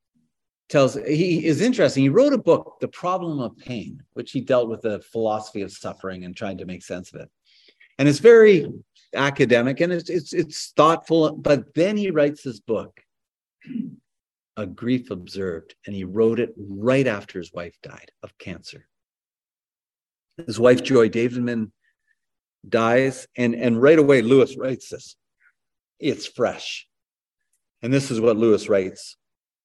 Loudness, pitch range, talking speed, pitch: -20 LUFS, 110-155 Hz, 155 wpm, 130 Hz